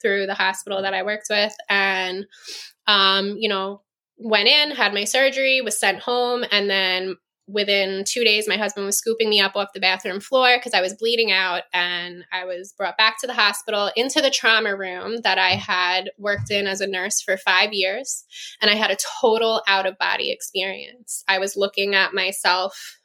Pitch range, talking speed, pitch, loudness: 190-220 Hz, 200 wpm, 200 Hz, -20 LUFS